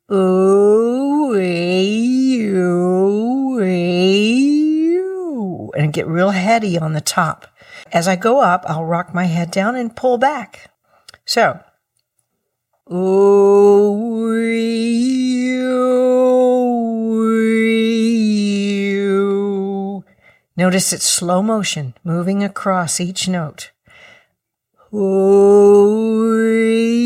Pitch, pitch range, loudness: 205 Hz, 185-230 Hz, -15 LUFS